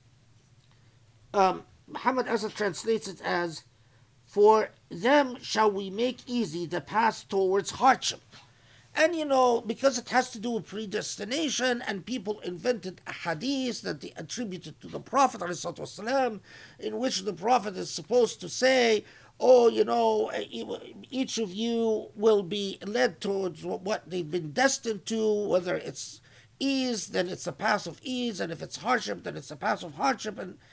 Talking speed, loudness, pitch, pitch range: 155 wpm, -28 LUFS, 215 Hz, 180-245 Hz